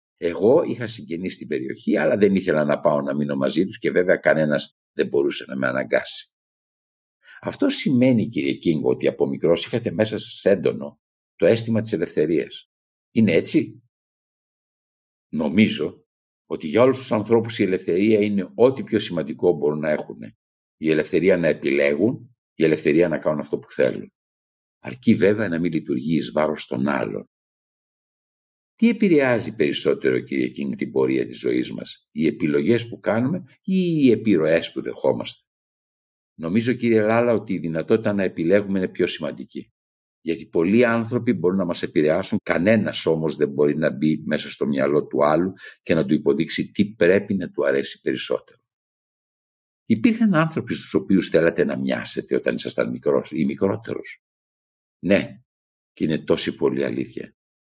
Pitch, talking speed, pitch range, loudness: 105 Hz, 155 wpm, 75-125 Hz, -21 LUFS